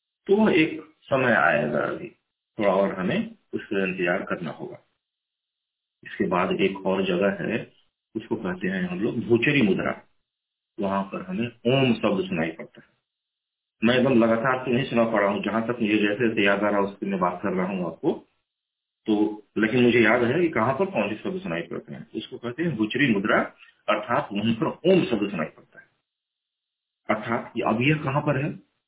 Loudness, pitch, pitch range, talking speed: -24 LUFS, 115 Hz, 105-145 Hz, 185 wpm